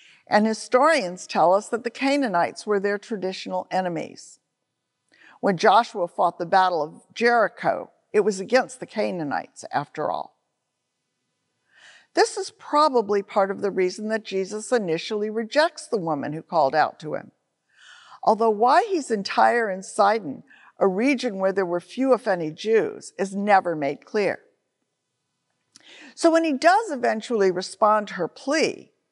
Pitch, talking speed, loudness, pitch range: 215 Hz, 145 wpm, -23 LUFS, 190-255 Hz